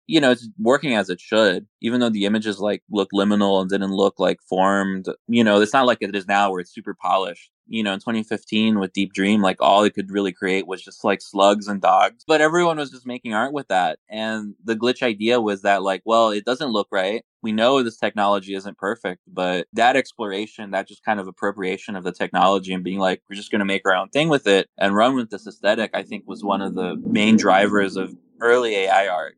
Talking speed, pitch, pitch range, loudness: 240 wpm, 100 Hz, 95-110 Hz, -20 LUFS